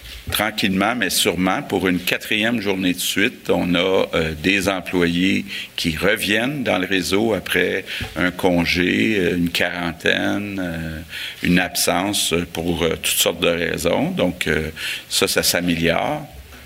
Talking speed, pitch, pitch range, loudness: 135 wpm, 90 Hz, 85-95 Hz, -19 LUFS